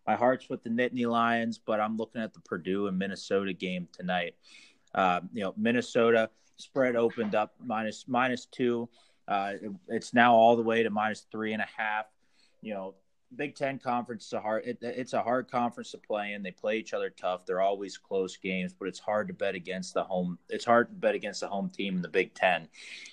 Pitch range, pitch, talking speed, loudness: 95-120 Hz, 110 Hz, 215 wpm, -30 LUFS